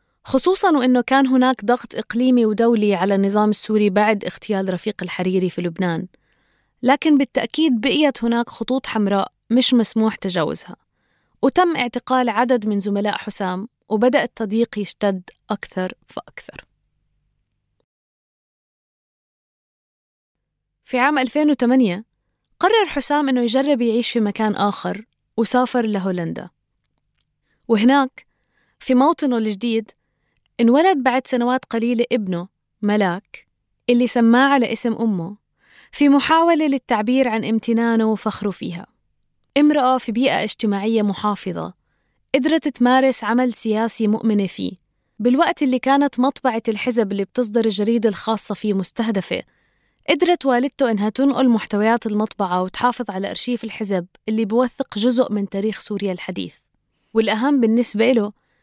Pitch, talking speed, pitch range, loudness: 230 Hz, 115 wpm, 210-255 Hz, -19 LUFS